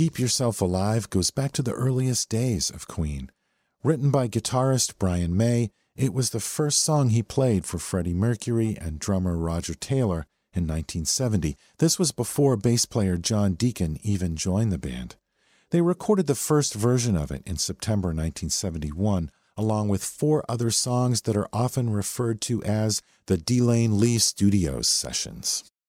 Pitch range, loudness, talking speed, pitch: 90-125 Hz, -25 LUFS, 160 wpm, 110 Hz